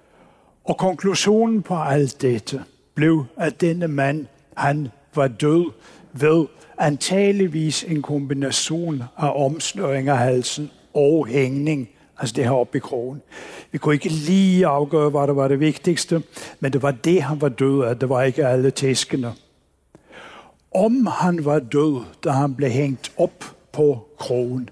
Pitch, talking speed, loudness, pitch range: 145 Hz, 150 wpm, -20 LUFS, 135-160 Hz